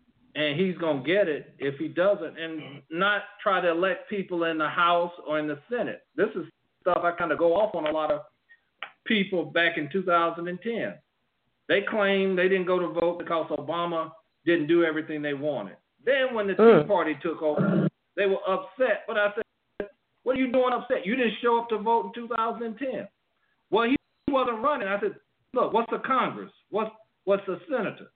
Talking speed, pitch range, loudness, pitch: 195 wpm, 165-225 Hz, -26 LUFS, 190 Hz